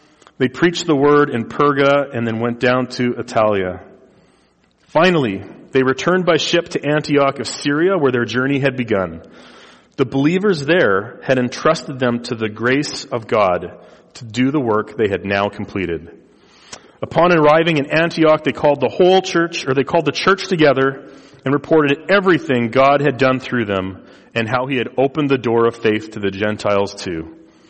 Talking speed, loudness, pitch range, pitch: 175 wpm, -17 LUFS, 115-150 Hz, 135 Hz